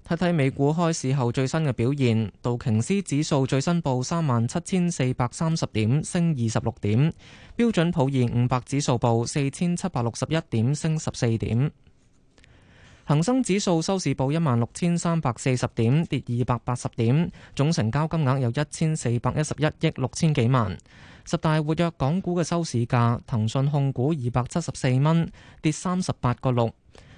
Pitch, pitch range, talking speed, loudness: 135 Hz, 120-165 Hz, 265 characters per minute, -24 LUFS